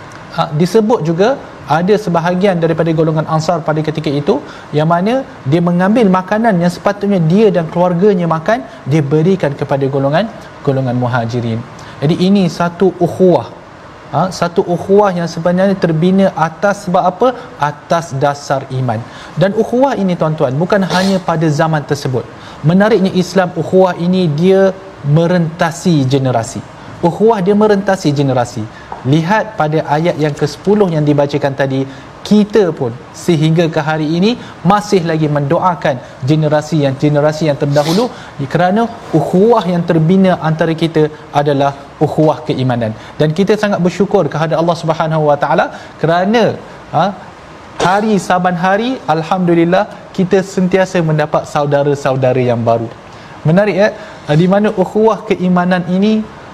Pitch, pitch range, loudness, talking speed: 170 Hz, 150-190 Hz, -13 LUFS, 130 wpm